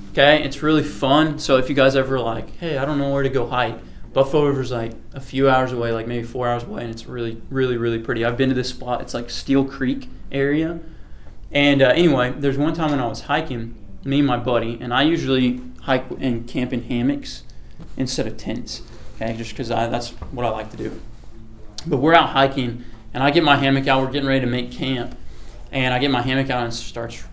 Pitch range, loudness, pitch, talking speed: 115-140 Hz, -20 LUFS, 130 Hz, 235 wpm